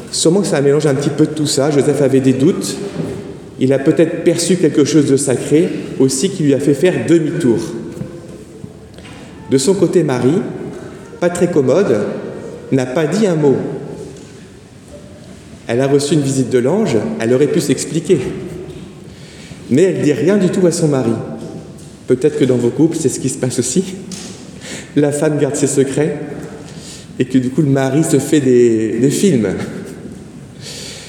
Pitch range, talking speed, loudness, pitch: 135-170 Hz, 170 wpm, -14 LUFS, 150 Hz